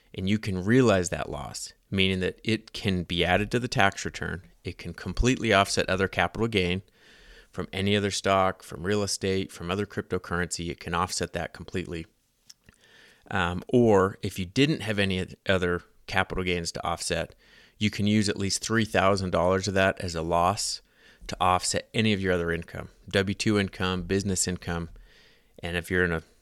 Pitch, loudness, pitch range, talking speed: 95 Hz, -27 LUFS, 90-105 Hz, 175 wpm